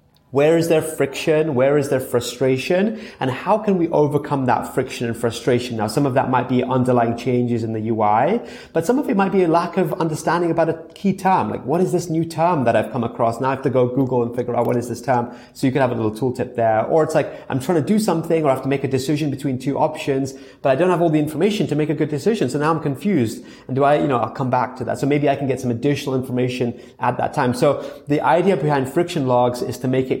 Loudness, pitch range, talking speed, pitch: -20 LUFS, 125-160 Hz, 275 wpm, 140 Hz